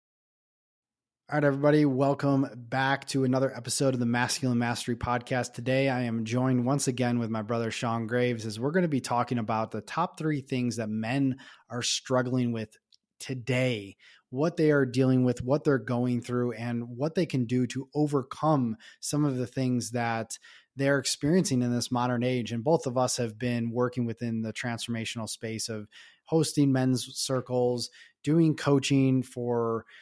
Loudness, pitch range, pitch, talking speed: -28 LUFS, 120-135 Hz, 125 Hz, 170 wpm